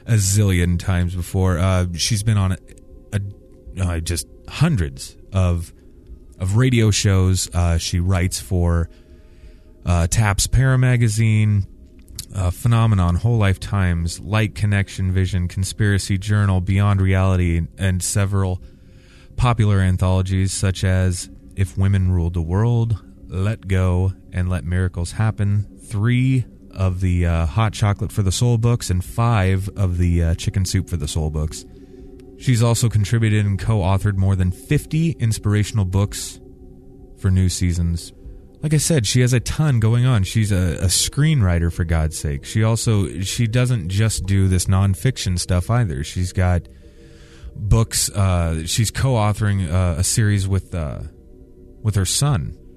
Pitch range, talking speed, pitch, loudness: 90-110 Hz, 145 wpm, 95 Hz, -19 LUFS